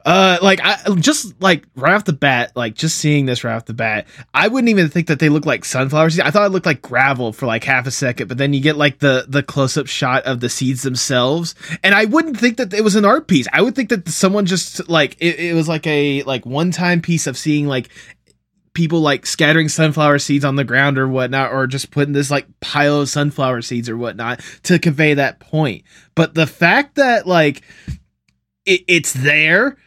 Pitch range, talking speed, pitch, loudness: 135-175 Hz, 225 wpm, 150 Hz, -15 LUFS